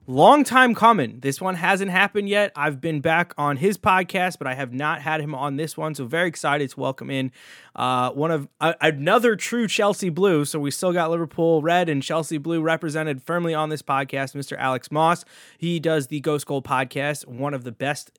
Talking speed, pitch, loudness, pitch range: 210 wpm, 155 Hz, -22 LUFS, 140-175 Hz